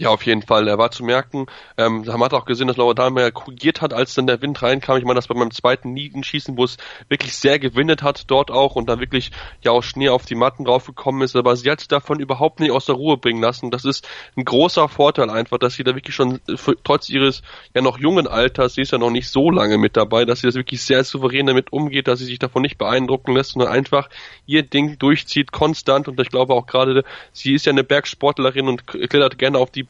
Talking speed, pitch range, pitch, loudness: 250 wpm, 125-140 Hz, 130 Hz, -18 LUFS